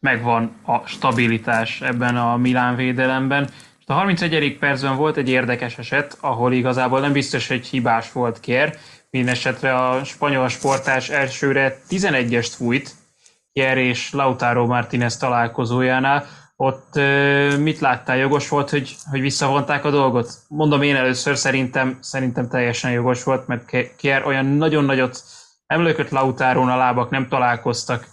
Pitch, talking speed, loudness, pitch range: 130 Hz, 135 wpm, -19 LUFS, 125-140 Hz